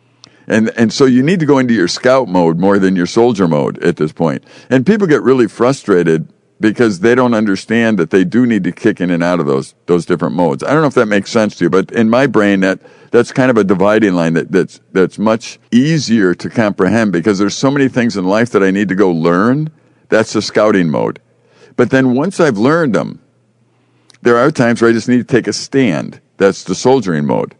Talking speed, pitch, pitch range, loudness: 235 wpm, 110 Hz, 95-125 Hz, -12 LUFS